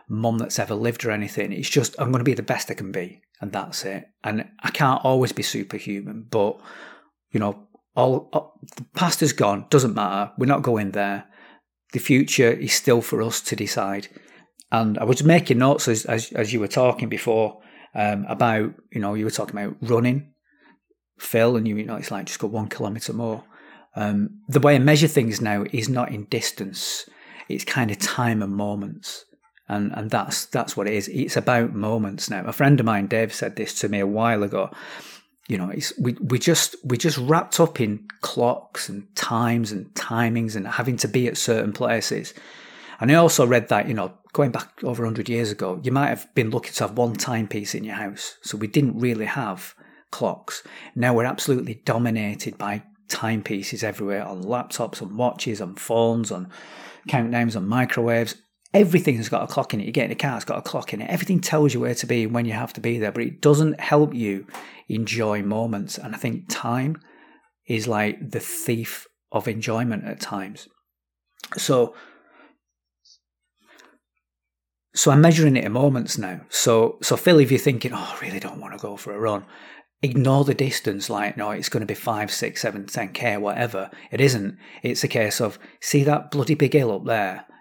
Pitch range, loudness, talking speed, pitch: 105-135 Hz, -23 LUFS, 200 wpm, 115 Hz